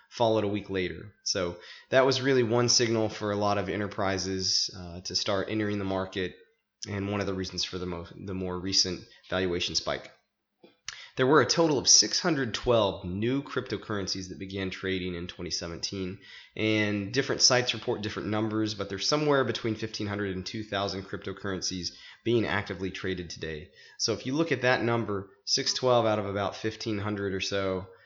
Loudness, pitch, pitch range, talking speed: -28 LUFS, 100 Hz, 95-110 Hz, 170 wpm